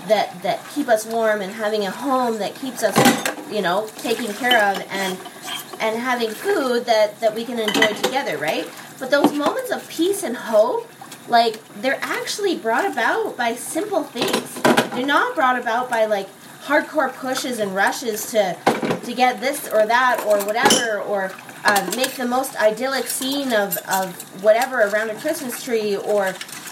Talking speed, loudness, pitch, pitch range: 170 wpm, -20 LUFS, 235 Hz, 210-265 Hz